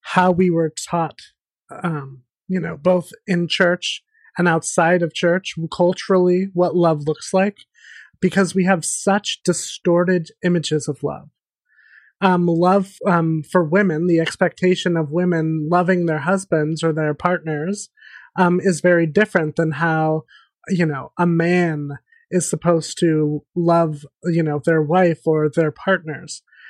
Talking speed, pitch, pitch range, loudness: 140 wpm, 175 Hz, 160-185 Hz, -19 LUFS